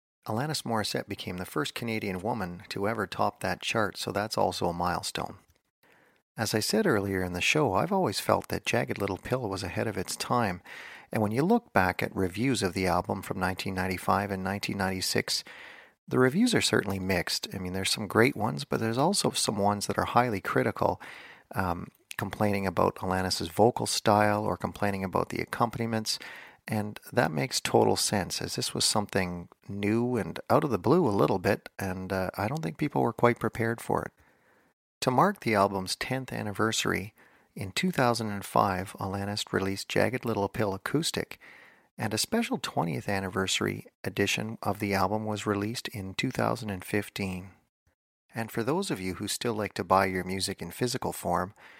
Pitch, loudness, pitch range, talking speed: 100 Hz, -29 LUFS, 95-110 Hz, 175 wpm